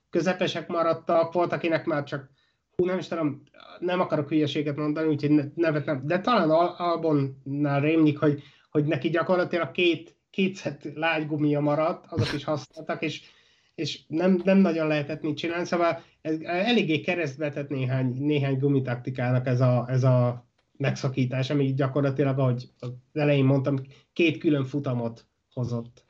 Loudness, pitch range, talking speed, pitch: -26 LUFS, 140-165 Hz, 145 wpm, 150 Hz